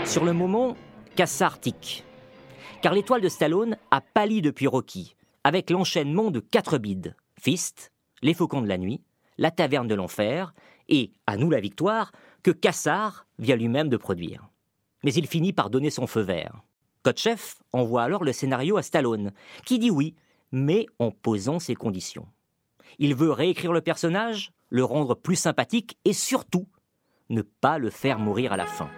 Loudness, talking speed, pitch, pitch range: -25 LUFS, 165 wpm, 155 Hz, 120-185 Hz